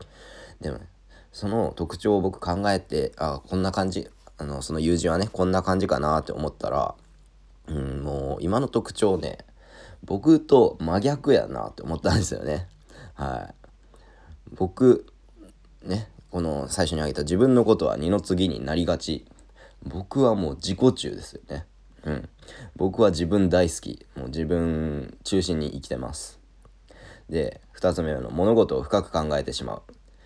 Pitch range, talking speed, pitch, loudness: 75-95 Hz, 270 characters per minute, 85 Hz, -25 LUFS